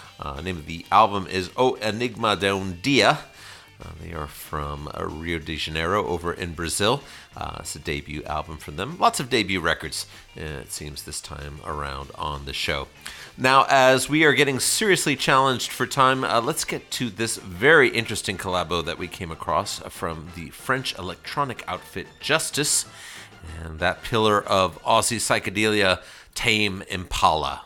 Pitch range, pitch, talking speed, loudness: 80-115 Hz, 95 Hz, 165 wpm, -23 LUFS